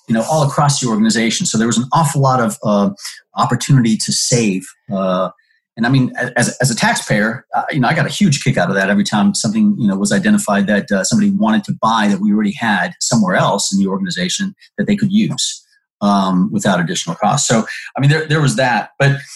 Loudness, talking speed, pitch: -15 LUFS, 230 wpm, 140 Hz